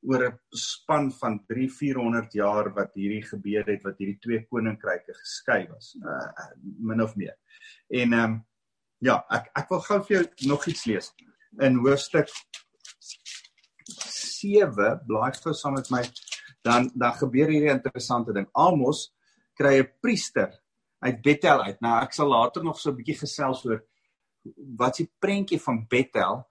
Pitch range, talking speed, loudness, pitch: 115-150 Hz, 160 wpm, -26 LUFS, 130 Hz